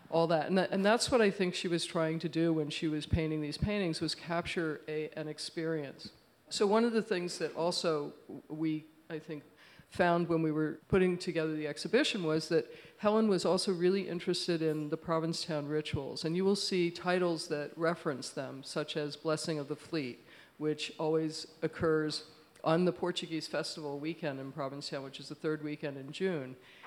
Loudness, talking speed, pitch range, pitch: -33 LUFS, 190 wpm, 155-175 Hz, 160 Hz